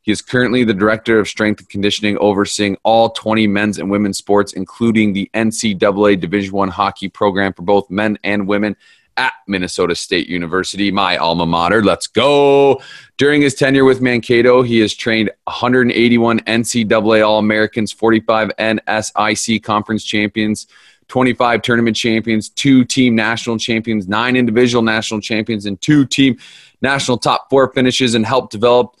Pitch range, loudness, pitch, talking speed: 105-120 Hz, -14 LUFS, 110 Hz, 155 wpm